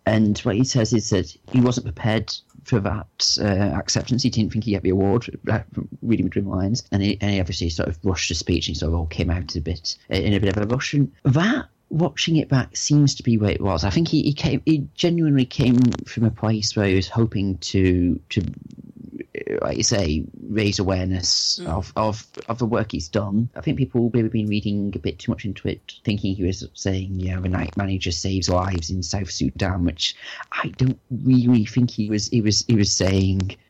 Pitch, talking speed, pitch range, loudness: 105 Hz, 220 wpm, 95-125 Hz, -22 LUFS